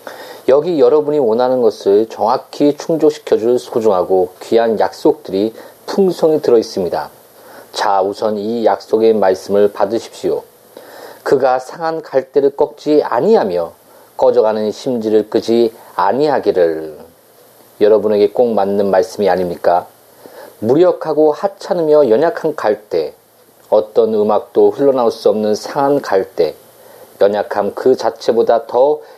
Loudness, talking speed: -14 LUFS, 275 characters per minute